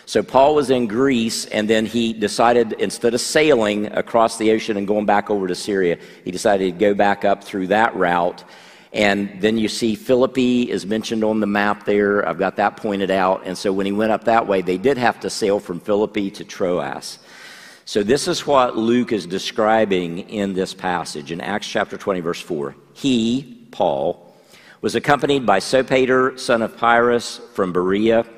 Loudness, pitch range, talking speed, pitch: -19 LUFS, 100-120 Hz, 190 wpm, 110 Hz